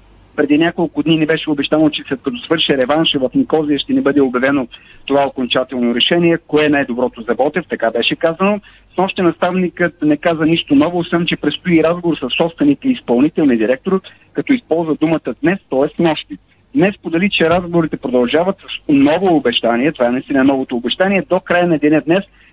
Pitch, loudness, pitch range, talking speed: 155 Hz, -15 LUFS, 135-175 Hz, 180 wpm